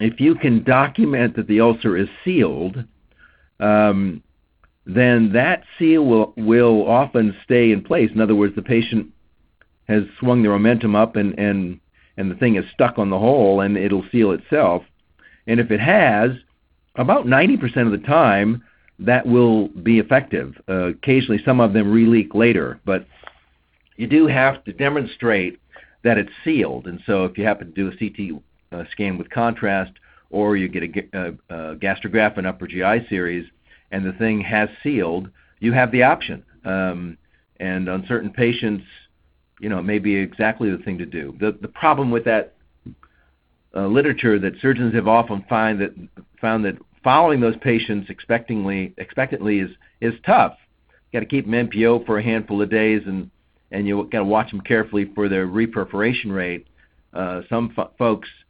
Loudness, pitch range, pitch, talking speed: -19 LUFS, 95-115 Hz, 105 Hz, 175 wpm